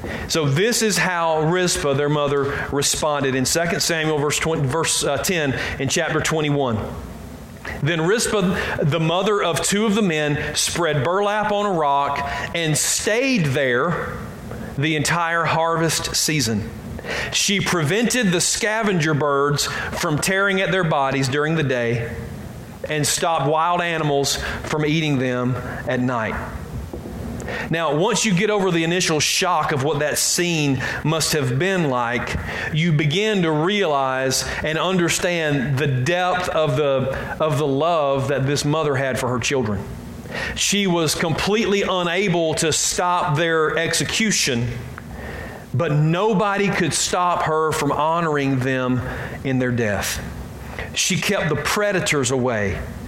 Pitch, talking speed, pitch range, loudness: 155 Hz, 135 wpm, 135-175 Hz, -20 LUFS